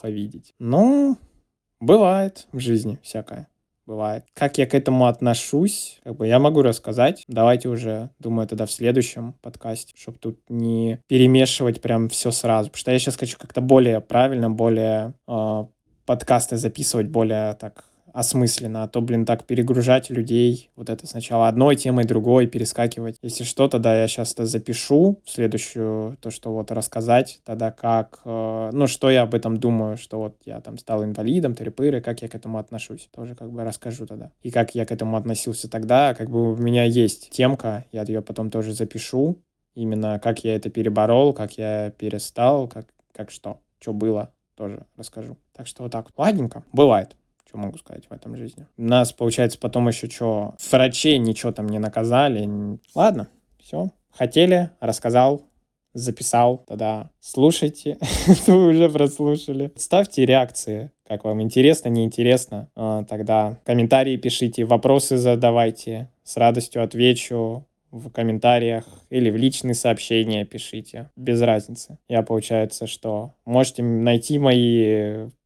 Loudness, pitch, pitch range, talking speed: -20 LUFS, 115 Hz, 110-130 Hz, 150 wpm